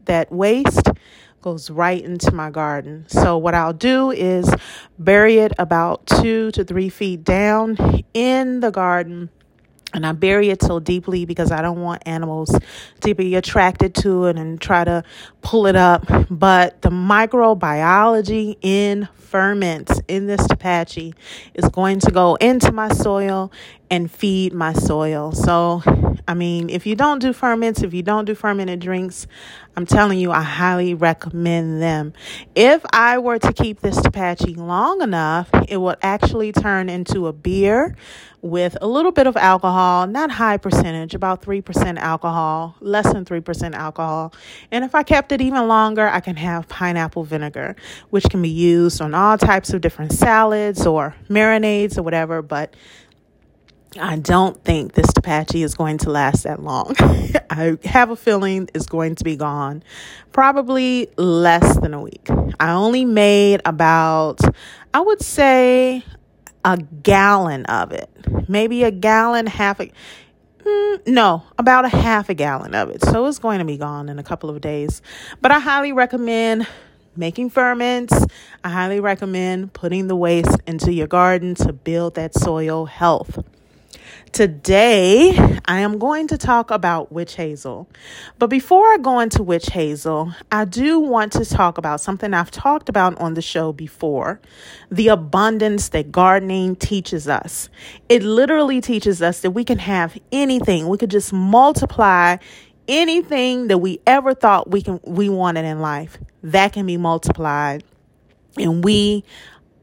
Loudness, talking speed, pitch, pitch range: -17 LUFS, 160 wpm, 185 Hz, 165-215 Hz